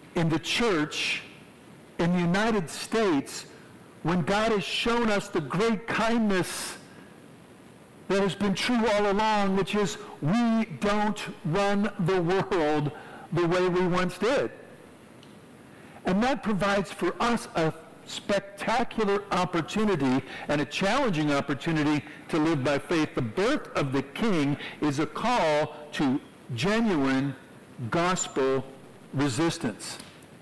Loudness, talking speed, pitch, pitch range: -27 LUFS, 120 wpm, 180 Hz, 150-205 Hz